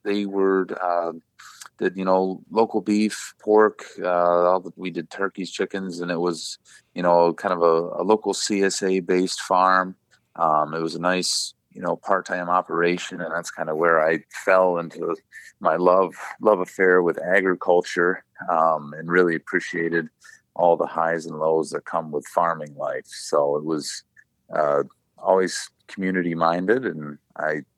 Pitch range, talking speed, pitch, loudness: 85-95 Hz, 160 wpm, 90 Hz, -22 LUFS